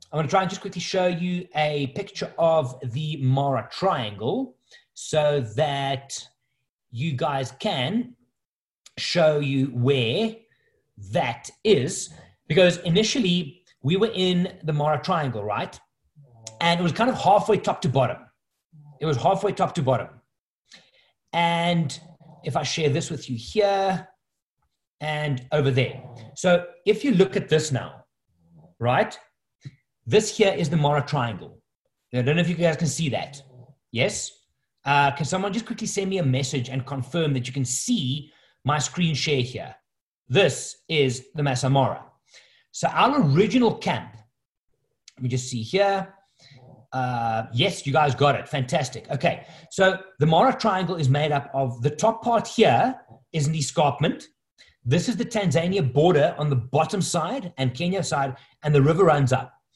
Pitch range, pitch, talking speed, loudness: 135-185 Hz, 150 Hz, 155 wpm, -23 LUFS